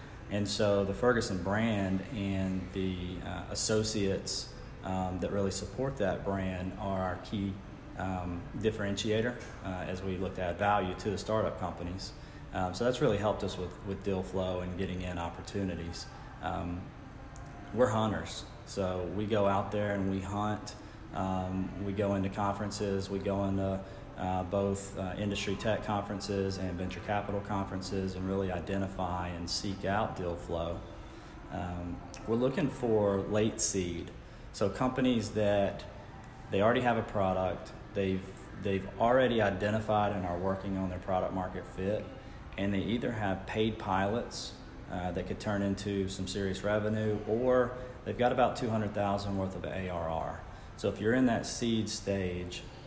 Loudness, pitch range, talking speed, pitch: -33 LUFS, 95-110 Hz, 155 wpm, 100 Hz